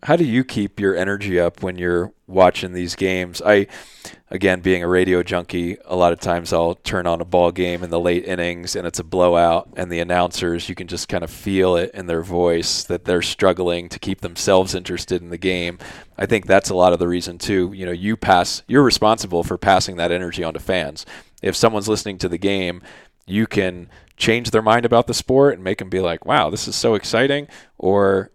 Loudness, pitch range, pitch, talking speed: -19 LUFS, 85-100 Hz, 90 Hz, 220 wpm